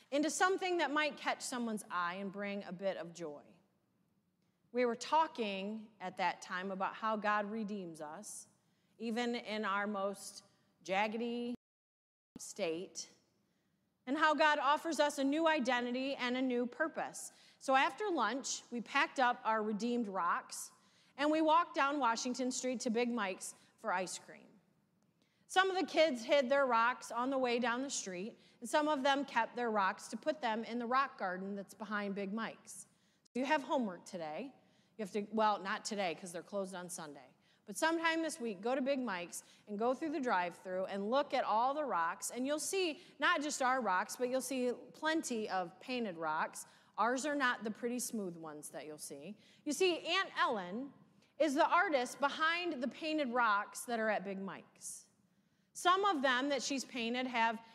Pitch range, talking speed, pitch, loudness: 195-275 Hz, 185 wpm, 230 Hz, -36 LUFS